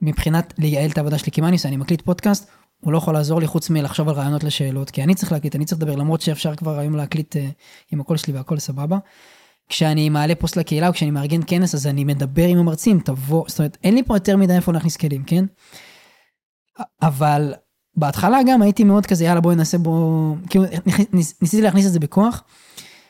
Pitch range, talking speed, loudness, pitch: 150-180 Hz, 195 wpm, -19 LUFS, 165 Hz